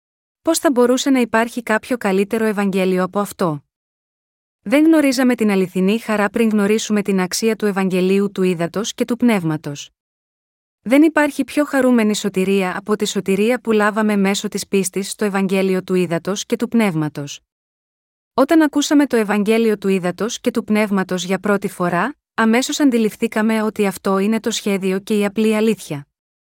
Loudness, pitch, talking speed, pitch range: -17 LUFS, 210 Hz, 155 wpm, 190-230 Hz